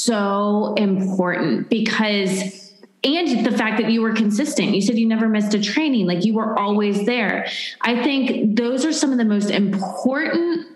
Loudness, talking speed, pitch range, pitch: -19 LUFS, 175 wpm, 205-245 Hz, 220 Hz